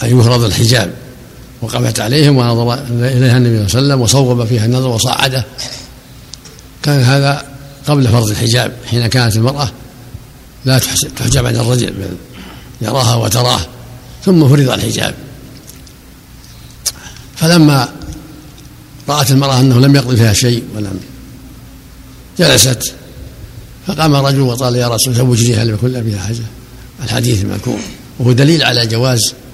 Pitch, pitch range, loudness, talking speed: 125 Hz, 120-135 Hz, -12 LUFS, 125 wpm